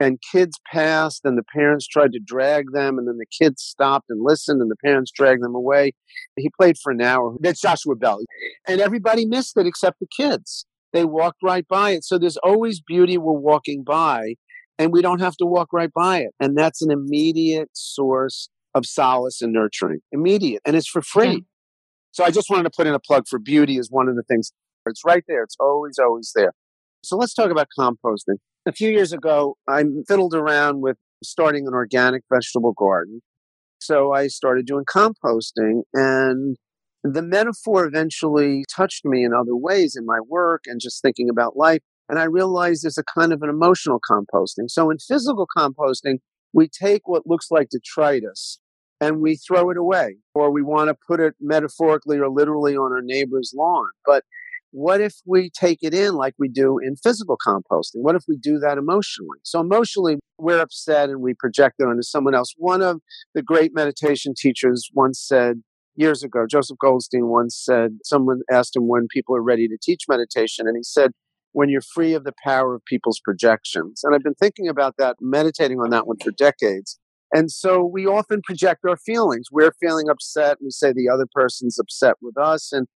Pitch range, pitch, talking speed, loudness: 130-170 Hz, 145 Hz, 195 wpm, -19 LUFS